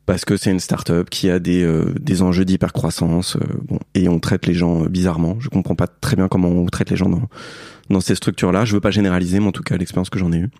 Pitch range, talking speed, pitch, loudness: 85-95 Hz, 285 wpm, 90 Hz, -18 LUFS